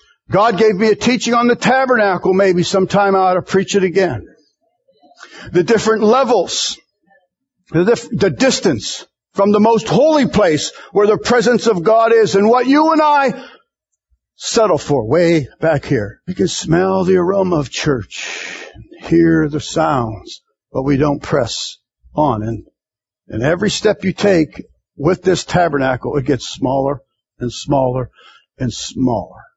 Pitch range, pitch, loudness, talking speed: 150-220 Hz, 190 Hz, -15 LUFS, 150 wpm